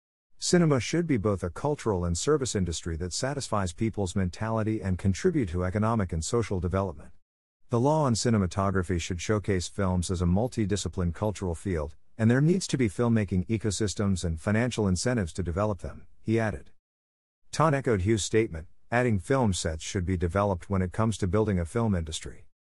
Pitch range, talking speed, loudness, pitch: 90-115 Hz, 170 wpm, -28 LUFS, 100 Hz